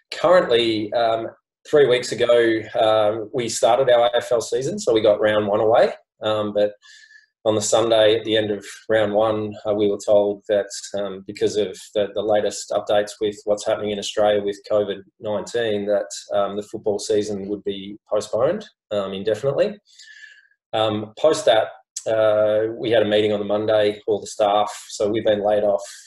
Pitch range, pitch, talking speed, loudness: 105-115 Hz, 105 Hz, 175 wpm, -20 LUFS